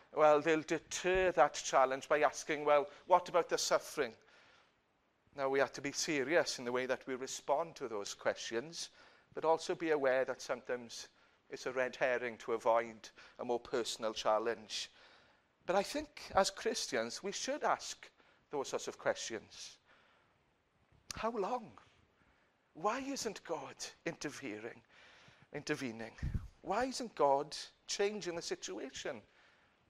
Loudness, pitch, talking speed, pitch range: -37 LUFS, 155 Hz, 135 wpm, 130-200 Hz